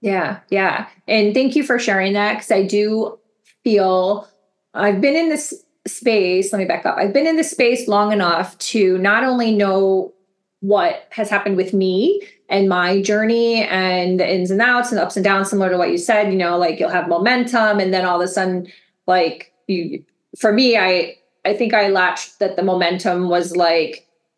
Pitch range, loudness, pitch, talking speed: 185-225 Hz, -17 LUFS, 200 Hz, 195 wpm